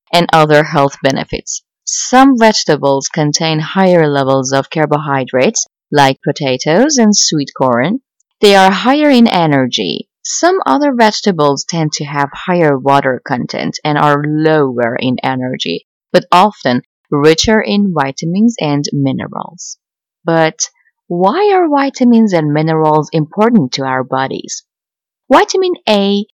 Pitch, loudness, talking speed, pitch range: 160 Hz, -12 LUFS, 125 wpm, 140-220 Hz